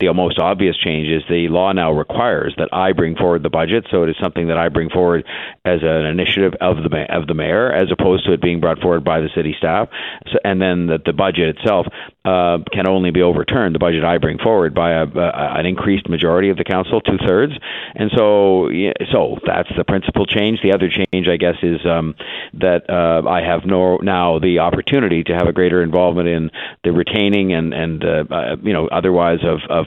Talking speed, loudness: 220 wpm, -16 LUFS